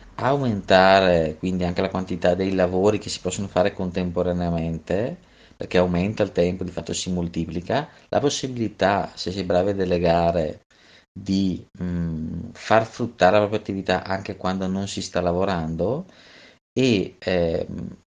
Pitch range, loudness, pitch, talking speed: 85-100 Hz, -23 LUFS, 90 Hz, 140 wpm